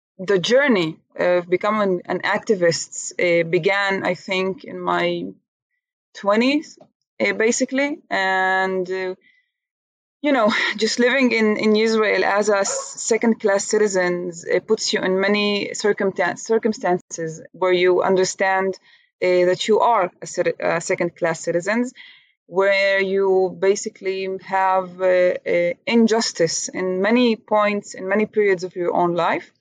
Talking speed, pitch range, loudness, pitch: 115 wpm, 180-220 Hz, -20 LUFS, 195 Hz